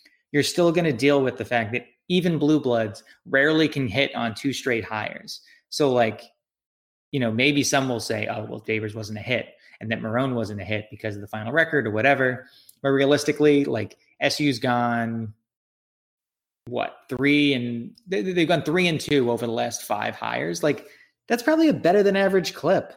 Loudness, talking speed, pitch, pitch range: -23 LUFS, 195 wpm, 135 Hz, 115-150 Hz